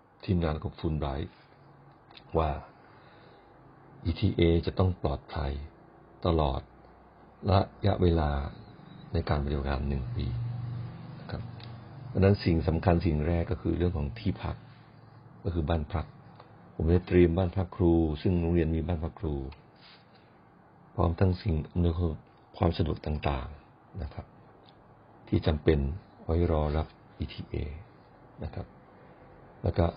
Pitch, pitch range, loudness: 85 Hz, 80-100 Hz, -30 LUFS